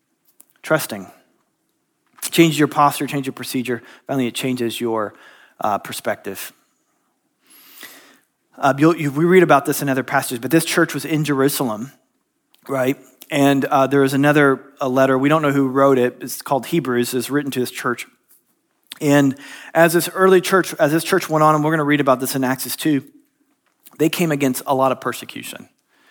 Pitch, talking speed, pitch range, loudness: 145 Hz, 180 wpm, 130-165 Hz, -18 LUFS